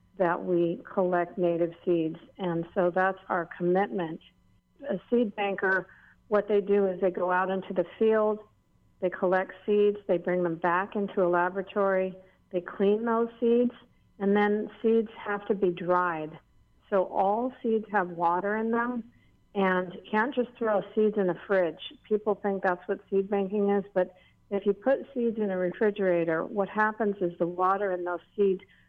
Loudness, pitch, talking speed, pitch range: -28 LUFS, 195 Hz, 170 wpm, 180-210 Hz